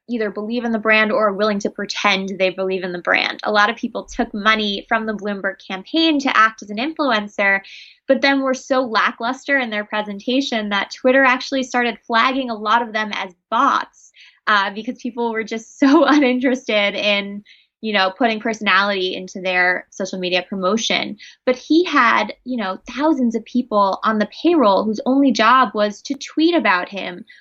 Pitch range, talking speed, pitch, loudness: 205-255 Hz, 185 wpm, 225 Hz, -18 LUFS